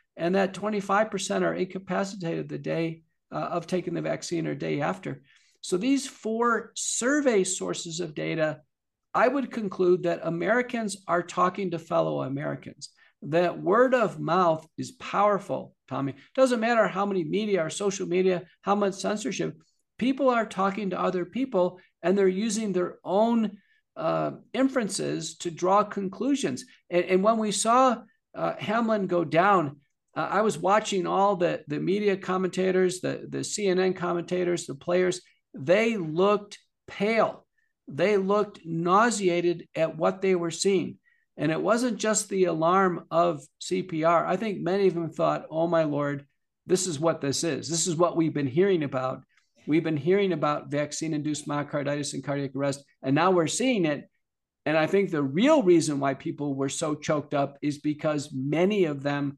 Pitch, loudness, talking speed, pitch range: 180 Hz, -26 LUFS, 160 wpm, 160-200 Hz